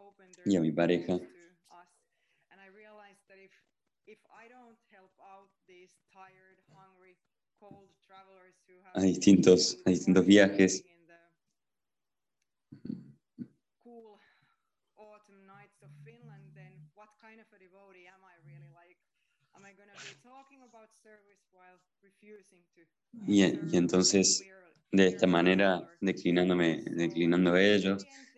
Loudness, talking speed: -27 LUFS, 40 wpm